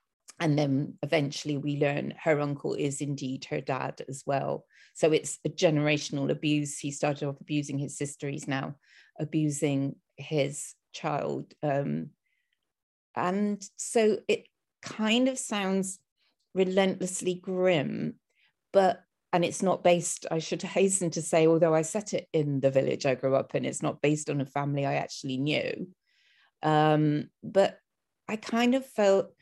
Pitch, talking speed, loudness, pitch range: 155 Hz, 150 wpm, -29 LUFS, 145-190 Hz